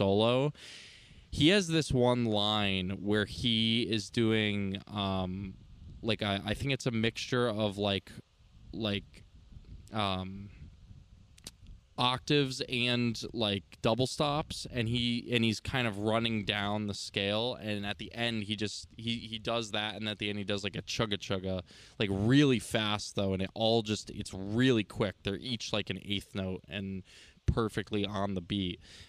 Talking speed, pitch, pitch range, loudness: 165 wpm, 105 Hz, 100-115 Hz, -32 LUFS